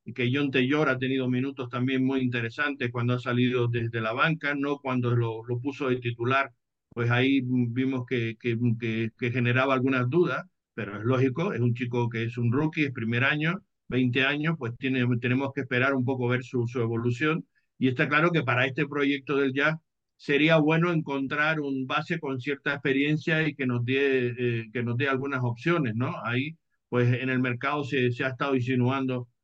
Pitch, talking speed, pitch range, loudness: 130 Hz, 190 wpm, 120-145 Hz, -27 LUFS